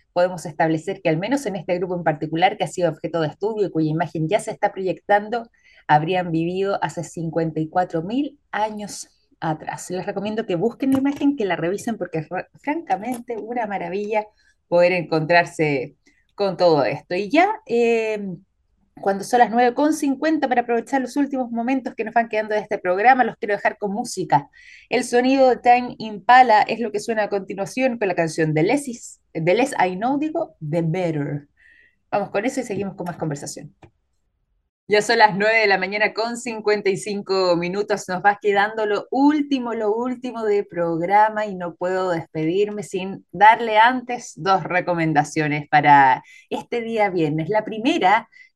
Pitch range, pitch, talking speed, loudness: 175-240 Hz, 205 Hz, 170 wpm, -21 LUFS